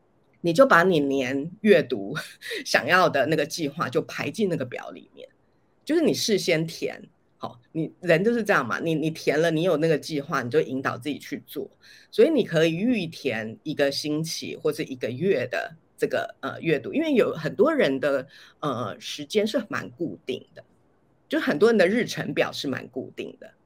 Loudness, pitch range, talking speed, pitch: -24 LUFS, 145-205 Hz, 265 characters per minute, 160 Hz